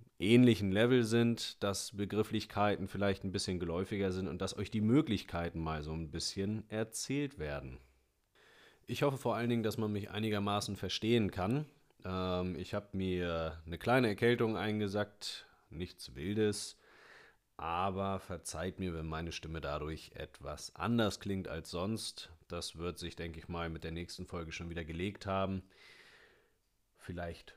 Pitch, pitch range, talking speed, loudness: 95 Hz, 85-110 Hz, 150 wpm, -36 LUFS